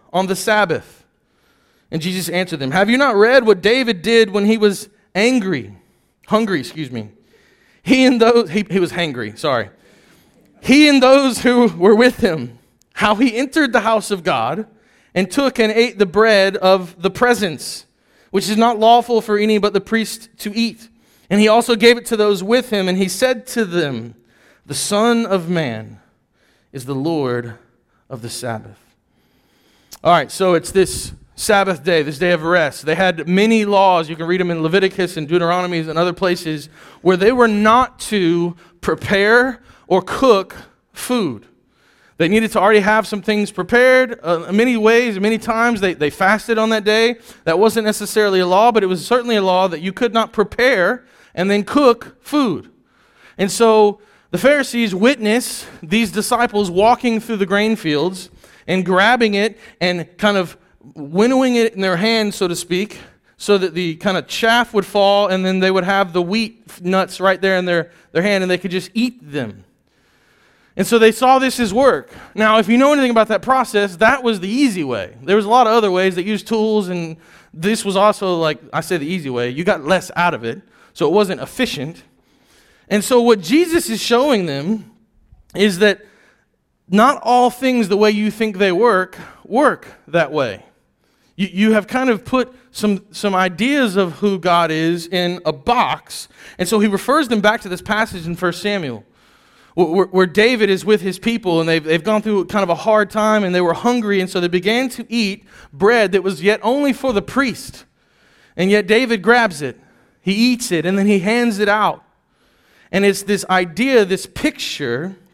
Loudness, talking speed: -16 LUFS, 190 wpm